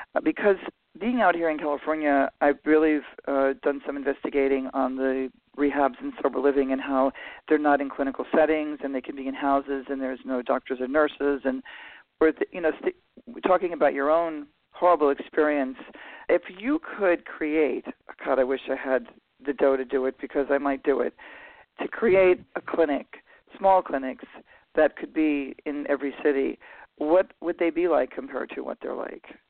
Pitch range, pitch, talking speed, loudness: 135-160 Hz, 145 Hz, 185 wpm, -25 LUFS